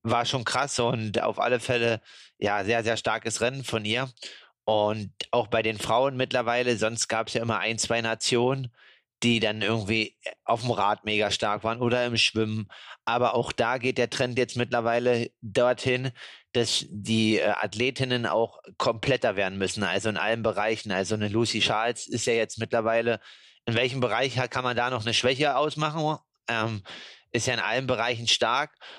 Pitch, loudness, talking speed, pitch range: 115 Hz, -26 LUFS, 175 wpm, 110-125 Hz